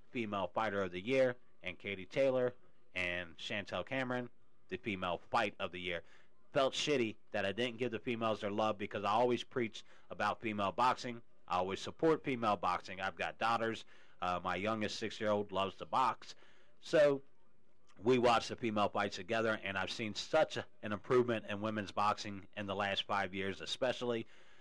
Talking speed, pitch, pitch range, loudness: 180 wpm, 110 Hz, 100-120 Hz, -37 LUFS